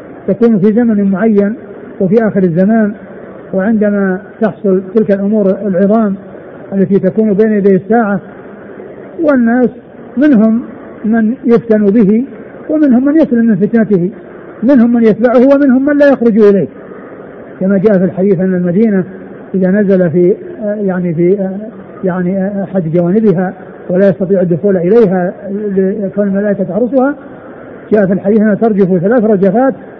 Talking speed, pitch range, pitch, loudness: 130 wpm, 195-225 Hz, 205 Hz, -11 LUFS